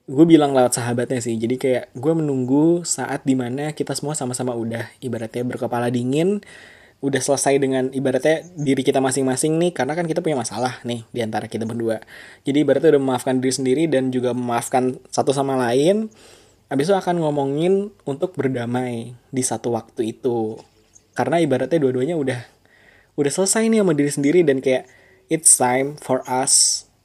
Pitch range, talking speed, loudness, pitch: 120-145 Hz, 160 wpm, -20 LUFS, 130 Hz